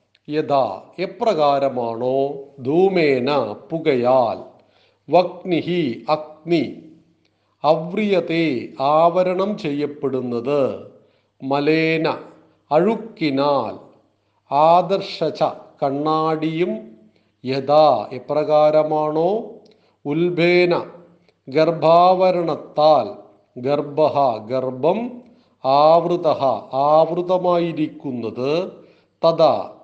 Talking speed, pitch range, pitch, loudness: 45 wpm, 140-175 Hz, 155 Hz, -19 LUFS